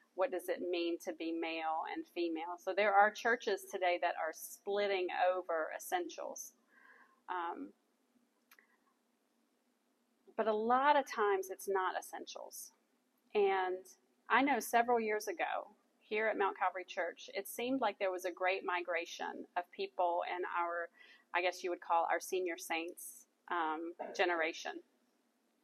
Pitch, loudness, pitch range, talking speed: 195 Hz, -37 LUFS, 175-240 Hz, 145 wpm